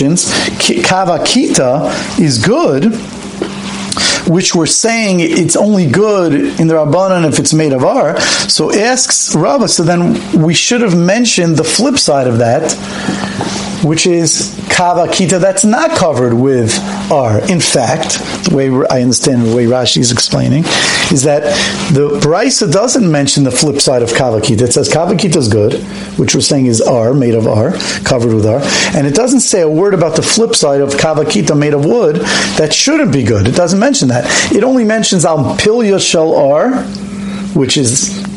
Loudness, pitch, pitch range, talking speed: -10 LUFS, 165 Hz, 140-200 Hz, 170 wpm